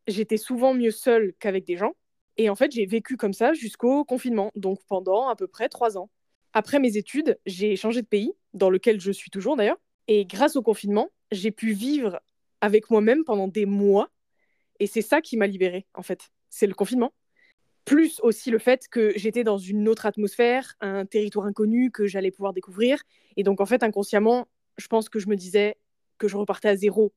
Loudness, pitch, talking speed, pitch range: -24 LUFS, 215 Hz, 205 wpm, 200-240 Hz